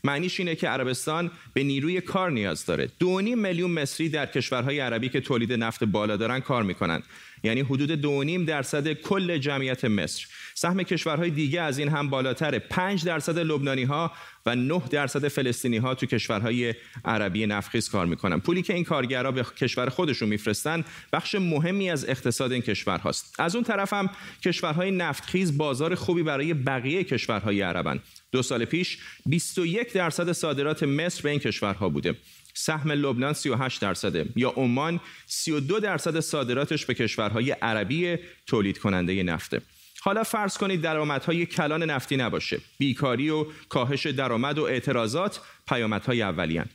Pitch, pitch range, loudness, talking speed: 145 Hz, 120-170 Hz, -27 LUFS, 155 wpm